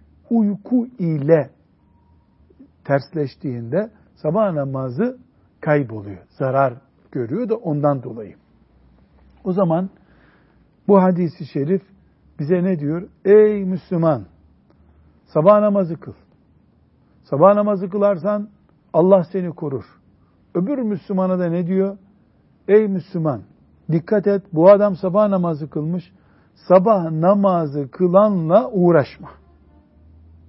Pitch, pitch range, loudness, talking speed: 170 Hz, 130-195 Hz, -18 LUFS, 95 wpm